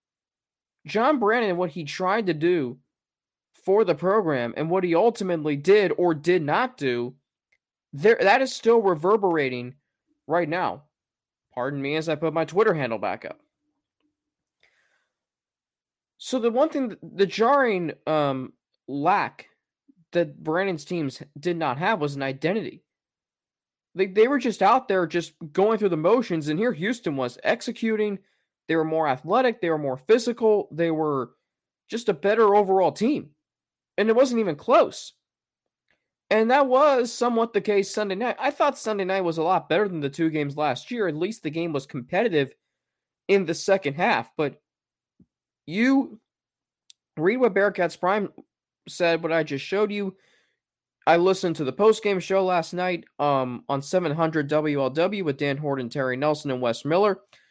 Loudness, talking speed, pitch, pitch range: -24 LUFS, 160 wpm, 180 Hz, 150-215 Hz